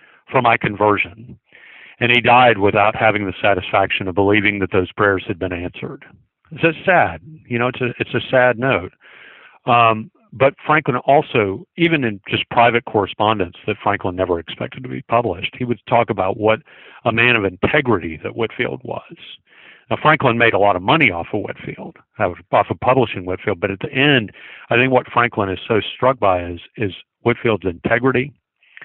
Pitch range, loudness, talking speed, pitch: 100-125 Hz, -17 LUFS, 180 wpm, 115 Hz